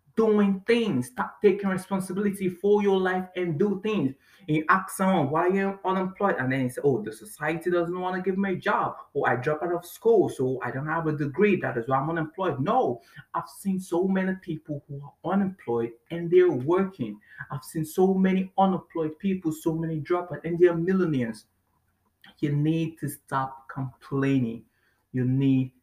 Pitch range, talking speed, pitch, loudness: 135-190 Hz, 185 wpm, 165 Hz, -26 LUFS